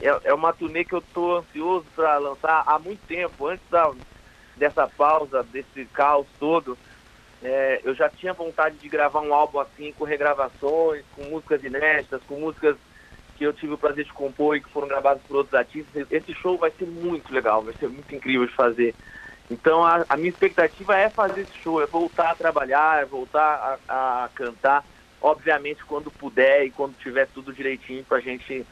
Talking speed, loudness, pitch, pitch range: 190 wpm, -23 LUFS, 150 Hz, 135-160 Hz